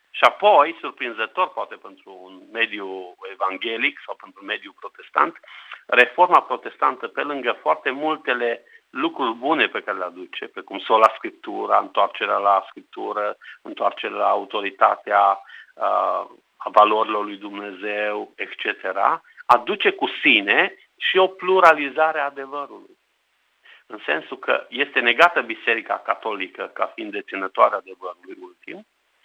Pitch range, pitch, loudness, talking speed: 105-165 Hz, 125 Hz, -20 LUFS, 125 wpm